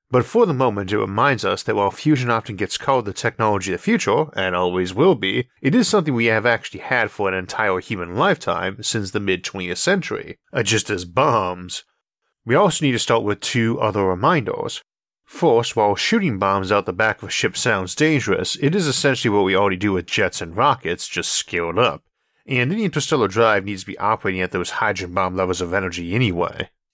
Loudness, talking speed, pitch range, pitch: -20 LUFS, 205 wpm, 95-130 Hz, 105 Hz